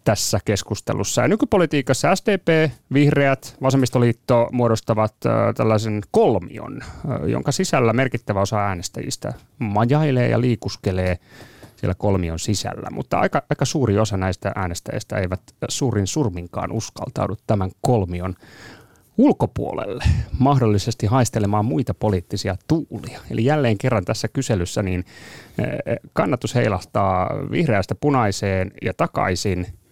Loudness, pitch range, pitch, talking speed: -21 LUFS, 100-135 Hz, 115 Hz, 105 wpm